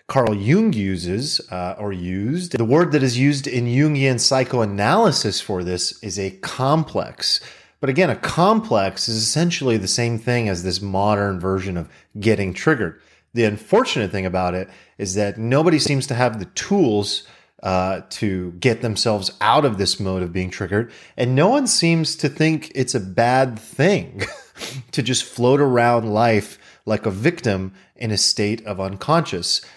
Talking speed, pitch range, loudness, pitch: 165 wpm, 95-135 Hz, -20 LUFS, 110 Hz